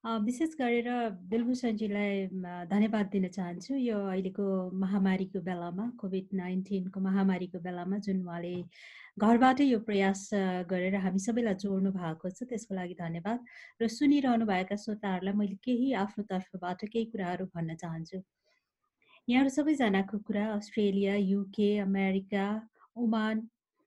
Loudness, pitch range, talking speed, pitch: -32 LUFS, 190-225 Hz, 115 wpm, 200 Hz